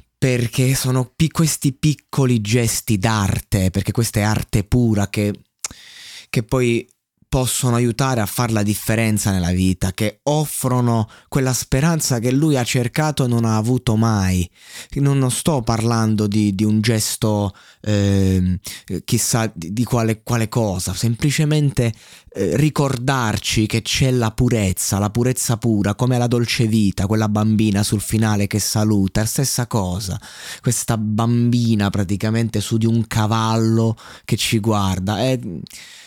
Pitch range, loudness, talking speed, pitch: 105-125 Hz, -19 LUFS, 140 wpm, 115 Hz